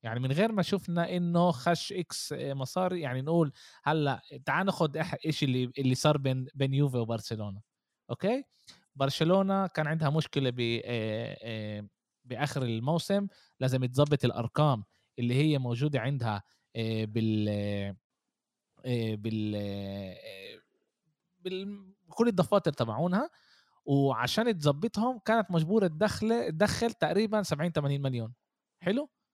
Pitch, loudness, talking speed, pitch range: 145 Hz, -30 LUFS, 110 wpm, 120-185 Hz